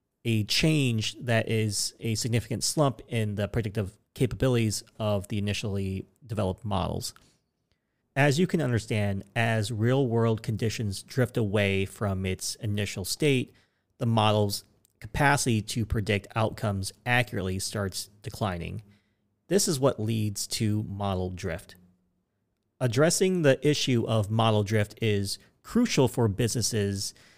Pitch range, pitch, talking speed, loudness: 100-120 Hz, 110 Hz, 125 wpm, -27 LUFS